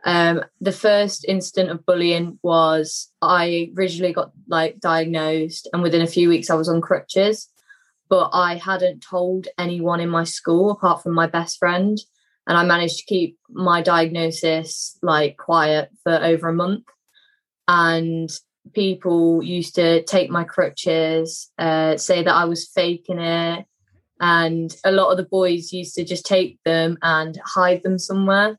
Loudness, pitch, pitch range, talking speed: -19 LUFS, 170 Hz, 165-185 Hz, 160 wpm